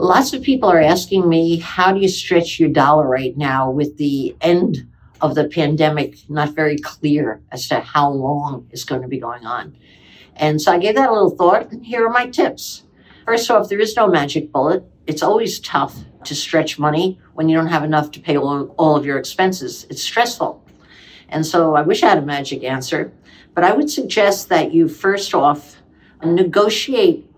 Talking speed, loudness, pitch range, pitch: 200 wpm, -17 LUFS, 145-190 Hz, 155 Hz